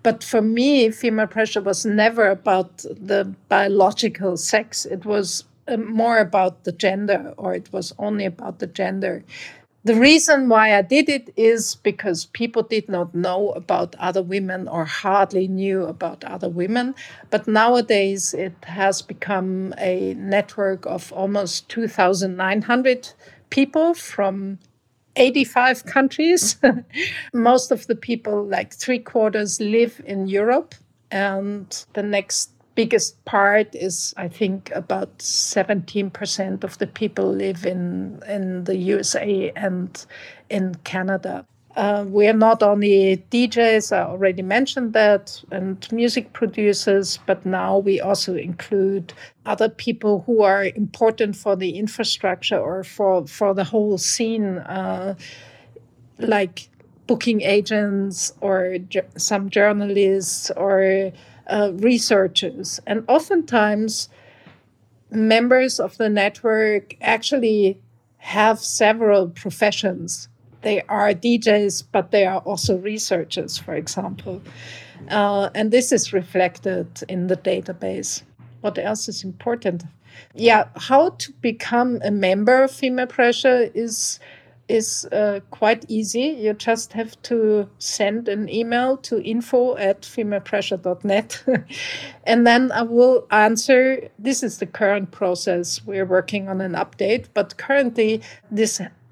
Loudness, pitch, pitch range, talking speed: -20 LUFS, 205 Hz, 190-225 Hz, 125 wpm